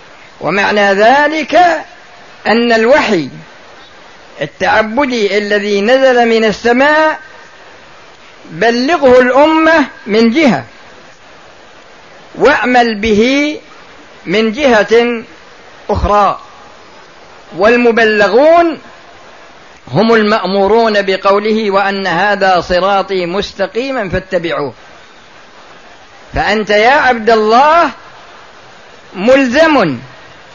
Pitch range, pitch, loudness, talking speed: 205-260 Hz, 225 Hz, -10 LUFS, 65 wpm